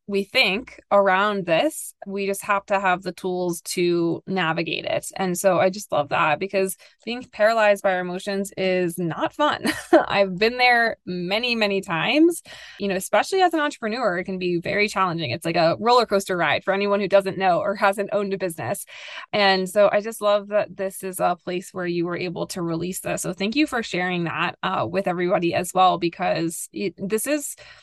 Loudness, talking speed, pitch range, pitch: -22 LUFS, 205 wpm, 180-210 Hz, 195 Hz